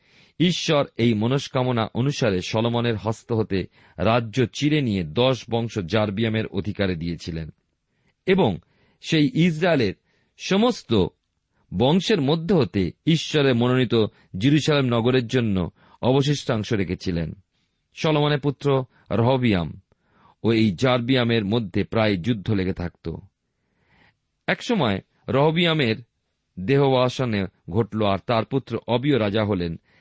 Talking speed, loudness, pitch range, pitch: 100 wpm, -22 LUFS, 100-135 Hz, 115 Hz